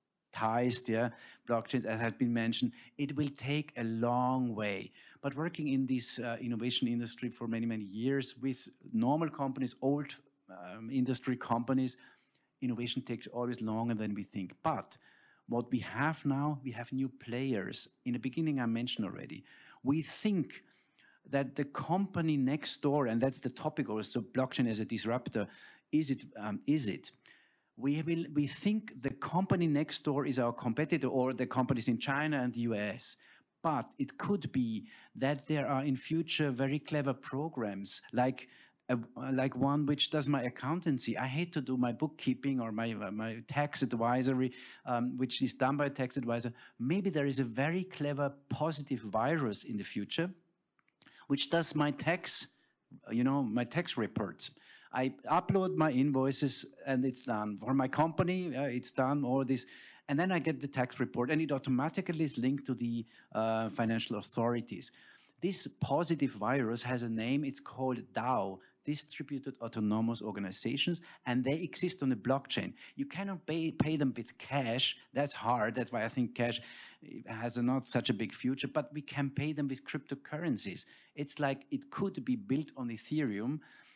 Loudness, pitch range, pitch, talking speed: -35 LUFS, 120-145 Hz, 130 Hz, 170 wpm